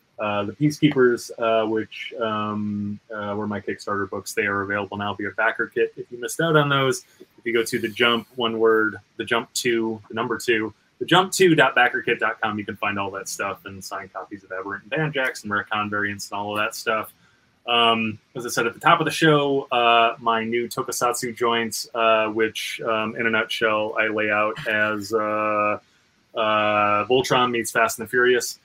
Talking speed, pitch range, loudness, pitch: 200 wpm, 105-120 Hz, -22 LUFS, 110 Hz